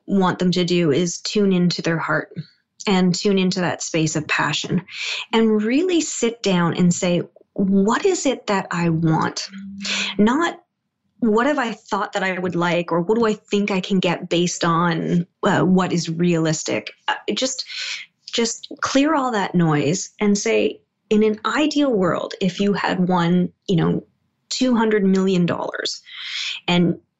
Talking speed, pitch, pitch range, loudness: 165 wpm, 195 Hz, 175-225 Hz, -20 LUFS